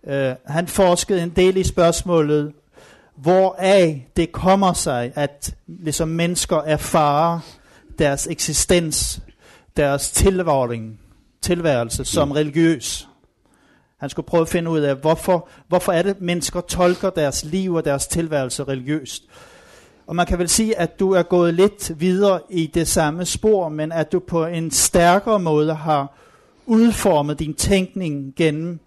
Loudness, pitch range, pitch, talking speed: -19 LUFS, 150-180 Hz, 165 Hz, 135 wpm